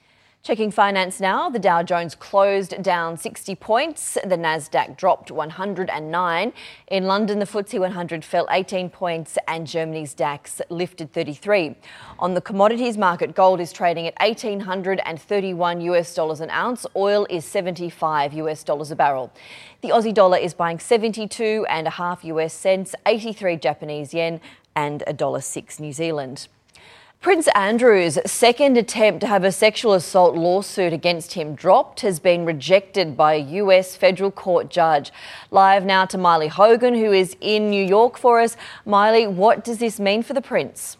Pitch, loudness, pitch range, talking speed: 185 Hz, -20 LUFS, 165-205 Hz, 155 wpm